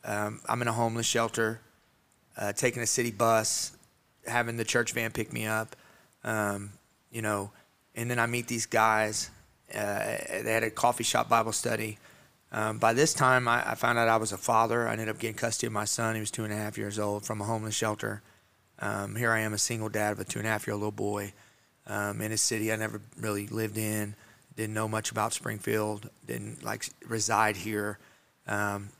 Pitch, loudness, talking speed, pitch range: 110 Hz, -30 LUFS, 215 wpm, 105-115 Hz